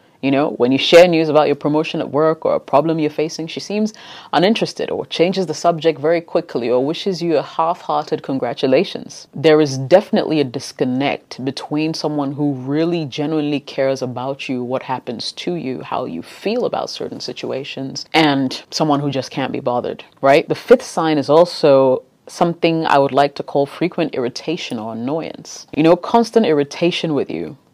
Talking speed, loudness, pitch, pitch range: 180 wpm, -17 LUFS, 155 Hz, 140-165 Hz